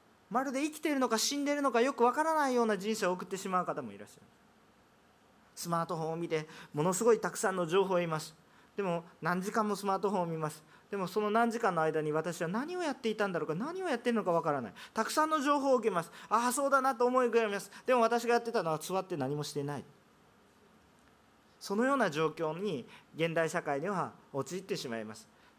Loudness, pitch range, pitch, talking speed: -32 LUFS, 165-240 Hz, 200 Hz, 480 characters per minute